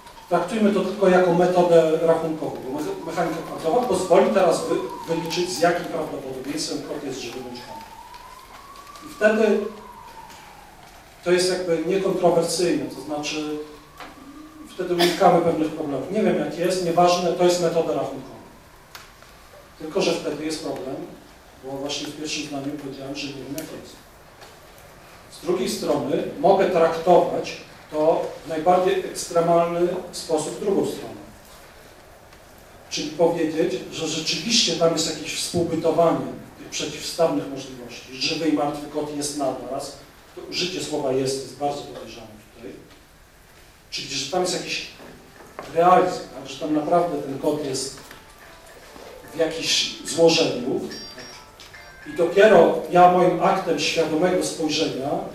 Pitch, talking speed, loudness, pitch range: 165 Hz, 125 wpm, -22 LUFS, 150-180 Hz